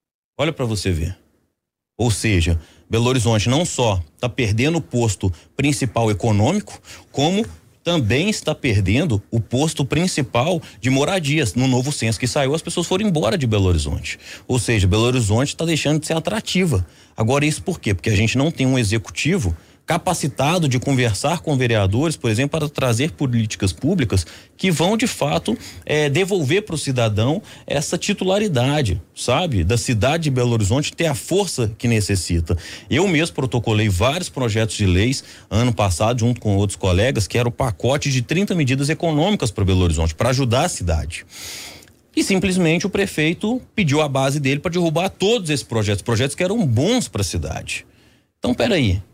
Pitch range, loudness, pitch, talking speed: 105-155 Hz, -19 LUFS, 125 Hz, 170 wpm